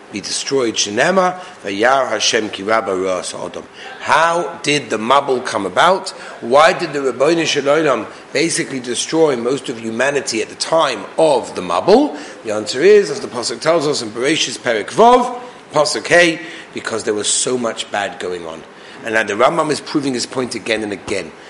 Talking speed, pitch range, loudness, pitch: 175 wpm, 110-180 Hz, -16 LUFS, 150 Hz